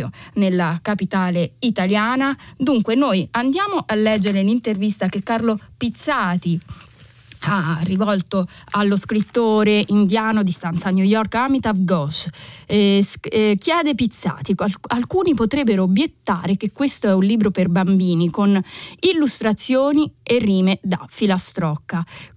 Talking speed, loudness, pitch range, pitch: 120 wpm, -18 LUFS, 185-230 Hz, 205 Hz